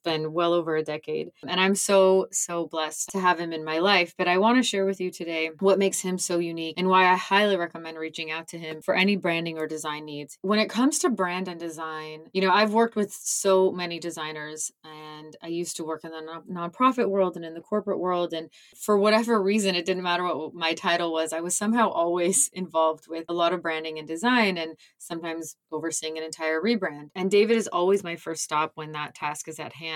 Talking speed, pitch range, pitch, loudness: 230 wpm, 160-190 Hz, 170 Hz, -25 LUFS